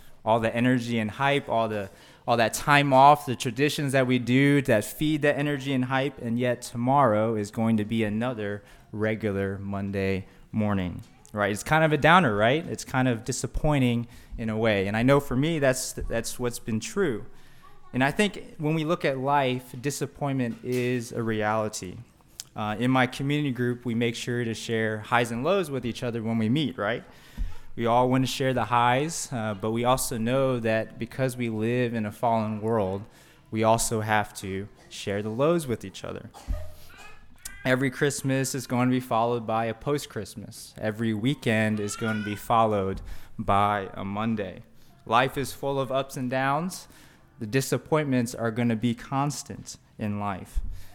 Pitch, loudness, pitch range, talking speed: 120 Hz, -26 LUFS, 110-135 Hz, 185 wpm